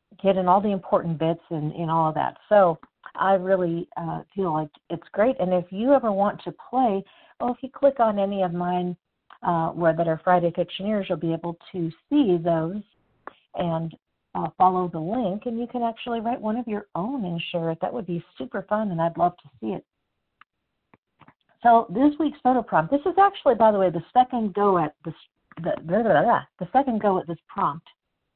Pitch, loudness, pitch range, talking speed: 185 Hz, -24 LUFS, 170-225 Hz, 215 wpm